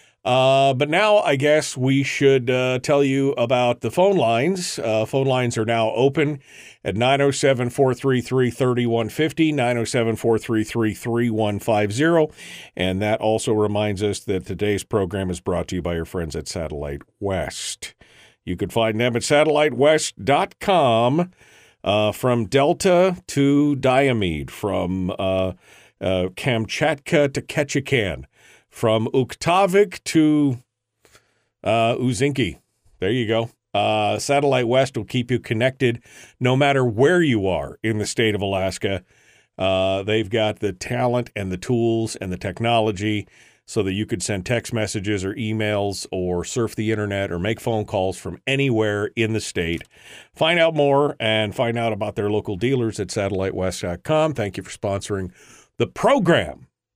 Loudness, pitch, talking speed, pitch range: -21 LUFS, 115 Hz, 145 wpm, 105-135 Hz